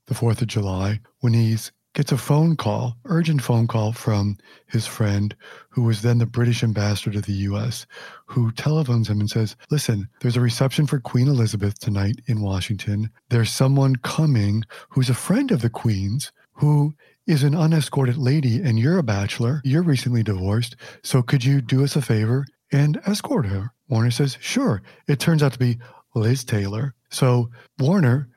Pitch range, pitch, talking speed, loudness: 110-140 Hz, 120 Hz, 175 wpm, -22 LUFS